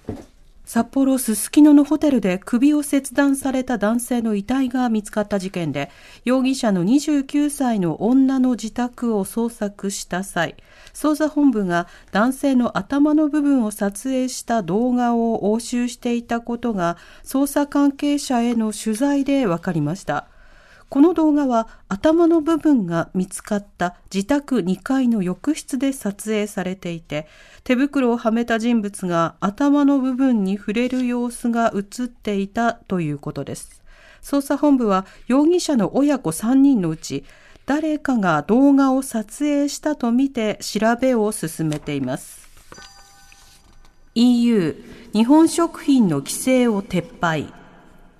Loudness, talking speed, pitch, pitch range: -20 LUFS, 255 characters per minute, 235 Hz, 195-275 Hz